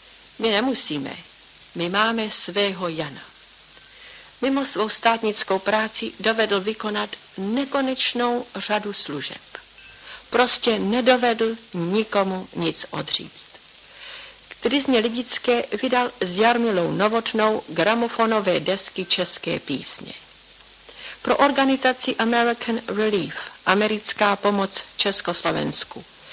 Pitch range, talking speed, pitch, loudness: 200-245 Hz, 85 wpm, 220 Hz, -21 LUFS